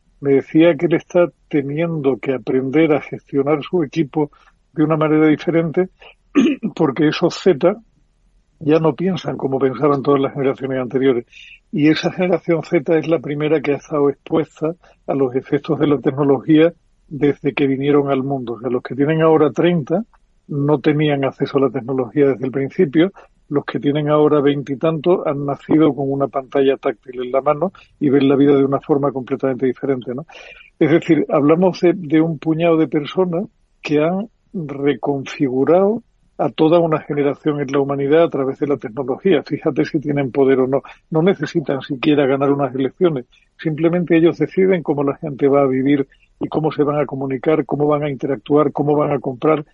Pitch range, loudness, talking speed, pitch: 140-160 Hz, -17 LUFS, 180 wpm, 150 Hz